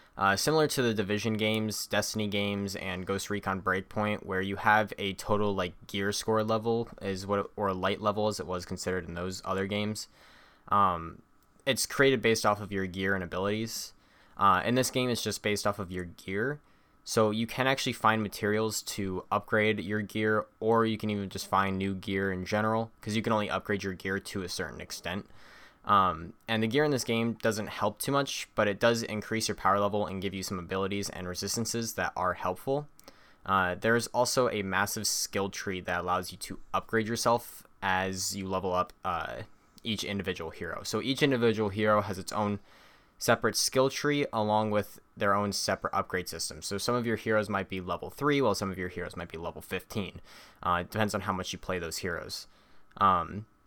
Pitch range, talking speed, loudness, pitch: 95-110 Hz, 205 wpm, -30 LUFS, 105 Hz